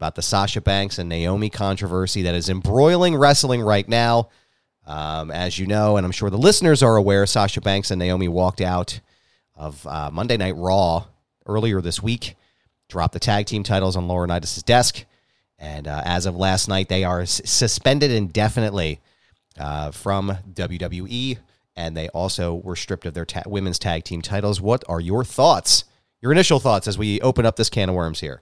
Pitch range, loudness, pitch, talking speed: 90-110 Hz, -20 LUFS, 100 Hz, 185 wpm